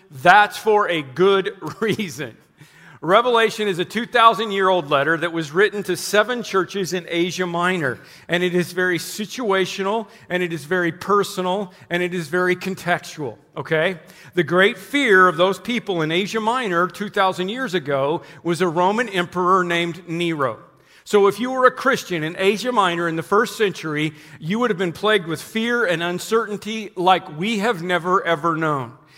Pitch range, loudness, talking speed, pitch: 170-205 Hz, -20 LUFS, 170 wpm, 185 Hz